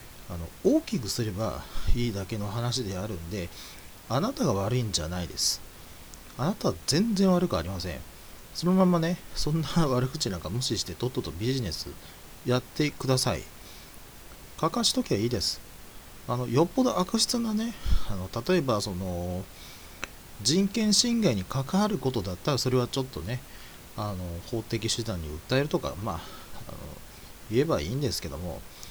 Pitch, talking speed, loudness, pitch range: 115 Hz, 320 characters per minute, -28 LUFS, 90-150 Hz